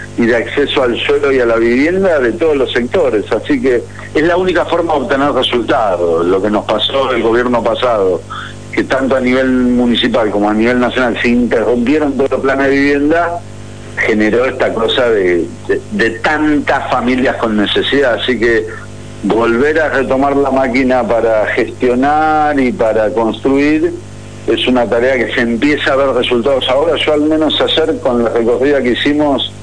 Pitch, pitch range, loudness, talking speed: 130 Hz, 115-150 Hz, -12 LUFS, 175 wpm